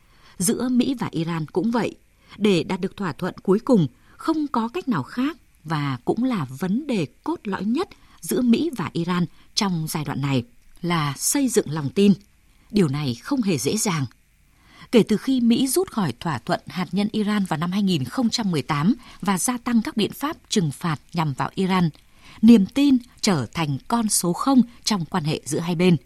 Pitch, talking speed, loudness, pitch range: 190 Hz, 190 wpm, -23 LUFS, 160-235 Hz